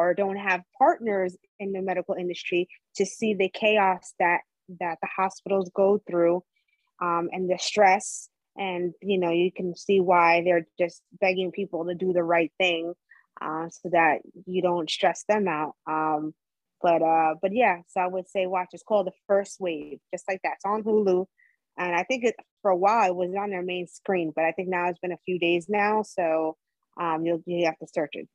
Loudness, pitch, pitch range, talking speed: -26 LUFS, 180 Hz, 170-195 Hz, 205 wpm